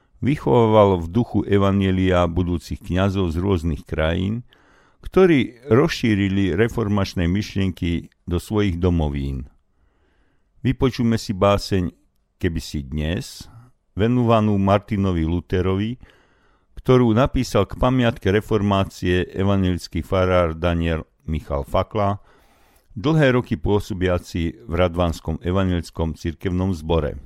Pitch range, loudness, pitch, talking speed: 85-105 Hz, -21 LUFS, 95 Hz, 95 wpm